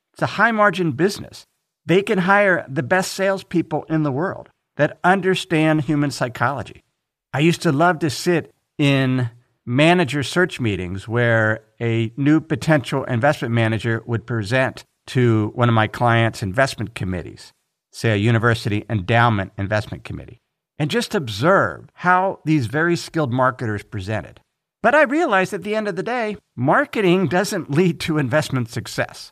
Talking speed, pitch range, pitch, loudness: 150 wpm, 115-180 Hz, 145 Hz, -19 LUFS